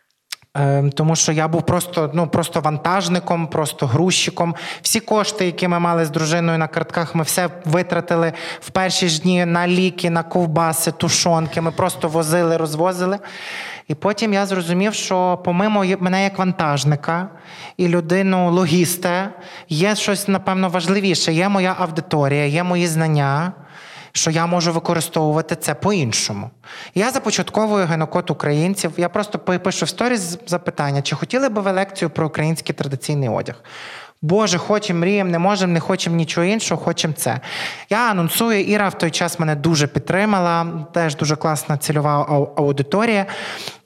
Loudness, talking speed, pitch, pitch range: -19 LUFS, 145 wpm, 175 Hz, 160-185 Hz